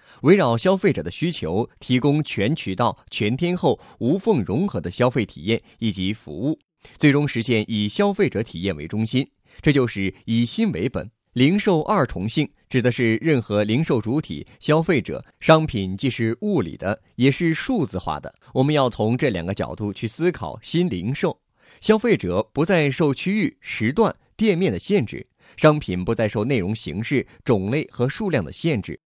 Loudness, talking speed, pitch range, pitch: -22 LUFS, 260 characters per minute, 110-155 Hz, 130 Hz